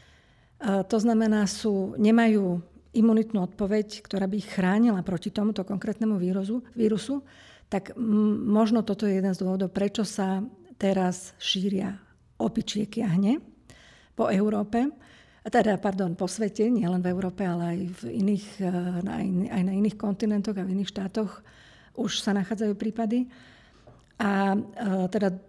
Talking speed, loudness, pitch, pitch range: 140 wpm, -27 LUFS, 205 Hz, 190-220 Hz